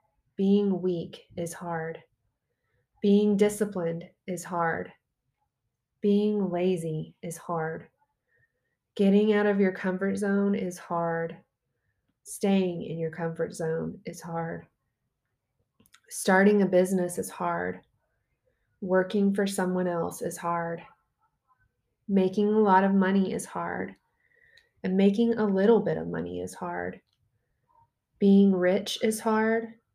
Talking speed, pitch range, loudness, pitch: 115 wpm, 165-205 Hz, -27 LUFS, 185 Hz